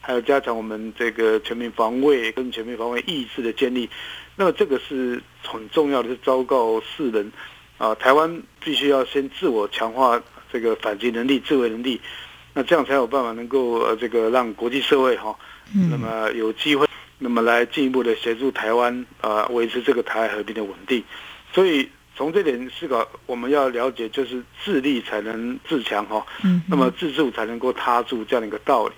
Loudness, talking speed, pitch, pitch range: -22 LUFS, 295 characters per minute, 120 Hz, 115-135 Hz